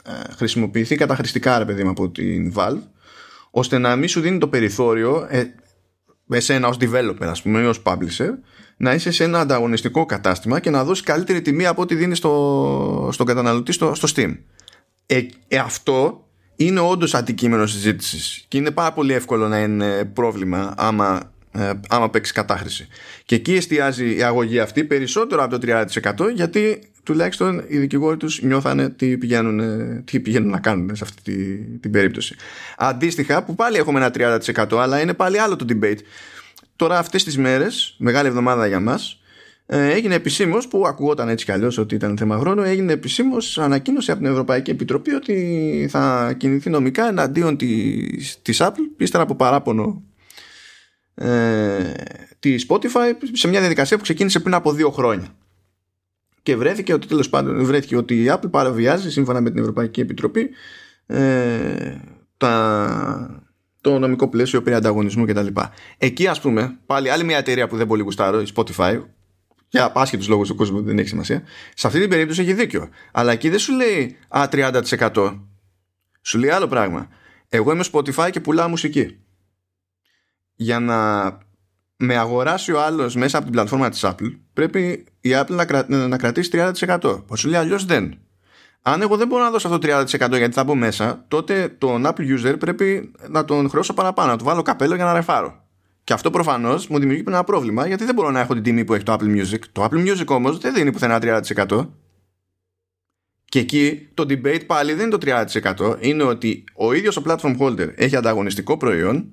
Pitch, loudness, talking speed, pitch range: 130 Hz, -19 LUFS, 175 wpm, 110-160 Hz